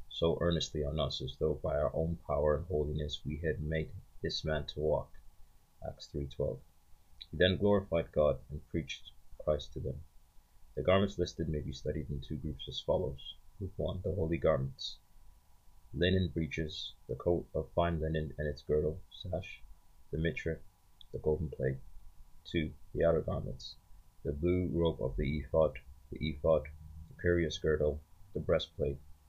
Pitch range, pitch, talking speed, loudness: 75-85 Hz, 80 Hz, 160 wpm, -35 LUFS